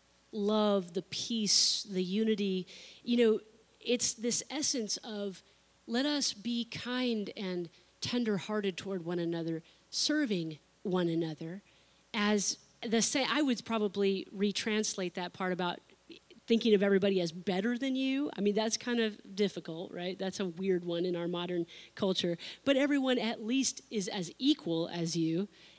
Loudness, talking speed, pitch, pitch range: -32 LUFS, 150 wpm, 205 Hz, 180-230 Hz